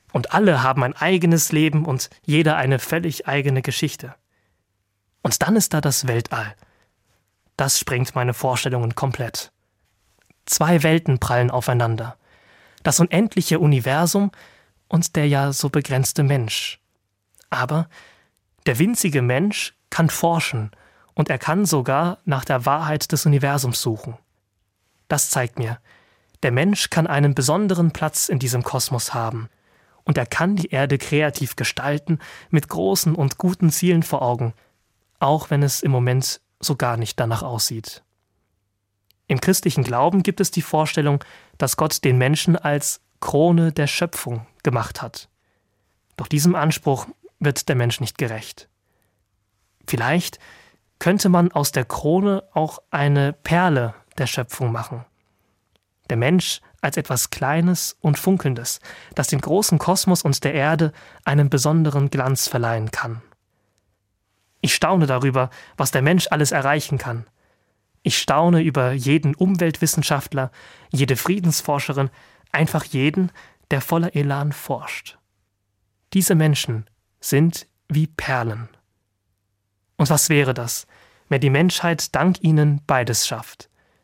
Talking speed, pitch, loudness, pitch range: 130 wpm, 140 Hz, -20 LUFS, 115-160 Hz